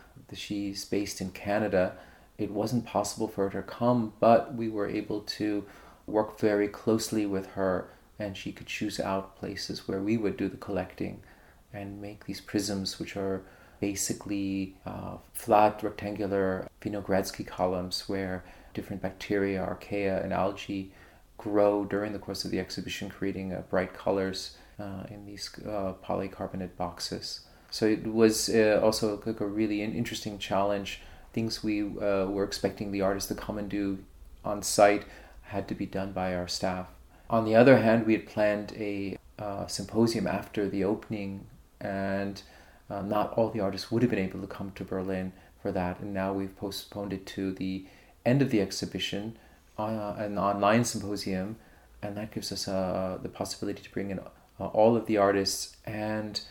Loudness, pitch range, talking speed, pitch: -30 LUFS, 95-105 Hz, 165 wpm, 100 Hz